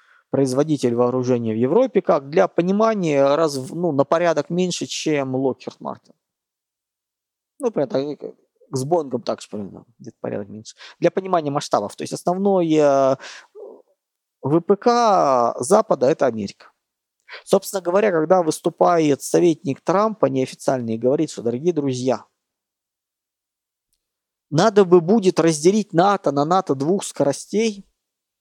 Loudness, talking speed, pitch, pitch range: -19 LUFS, 115 wpm, 160 Hz, 135-190 Hz